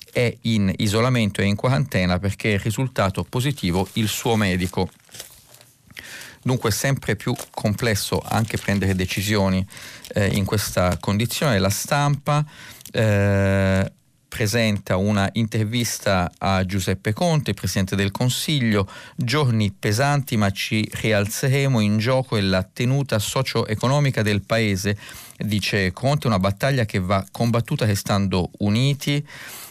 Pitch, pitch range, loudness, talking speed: 110 Hz, 100-125 Hz, -21 LUFS, 120 wpm